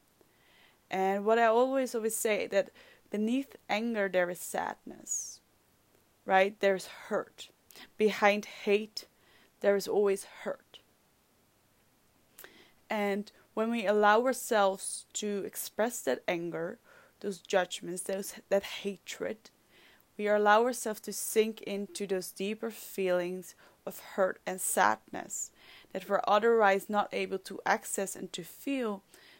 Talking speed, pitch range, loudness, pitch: 120 wpm, 195-220 Hz, -31 LUFS, 205 Hz